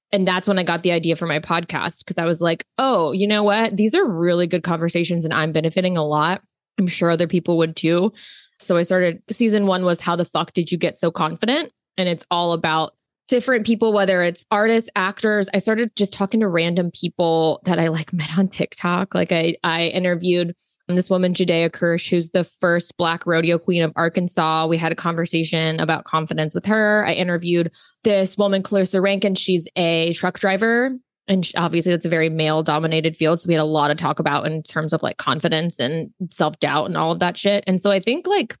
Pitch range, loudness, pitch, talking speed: 165-195 Hz, -19 LUFS, 175 Hz, 215 wpm